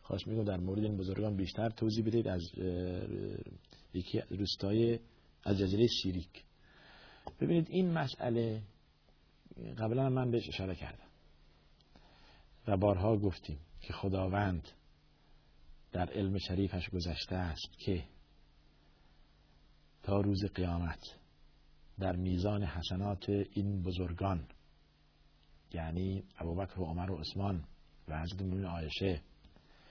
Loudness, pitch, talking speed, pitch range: -36 LUFS, 95 Hz, 100 wpm, 80-100 Hz